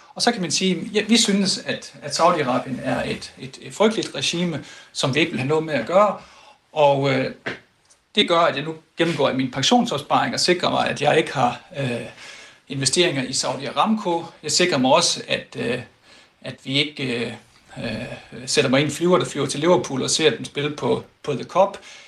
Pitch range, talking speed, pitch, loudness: 140-185 Hz, 200 wpm, 160 Hz, -21 LUFS